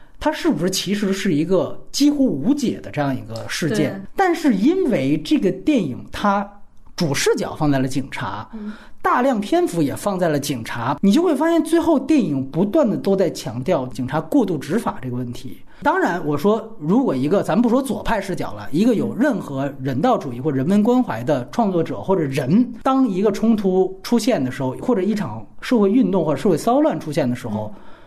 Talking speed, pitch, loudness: 300 characters per minute, 195 Hz, -20 LUFS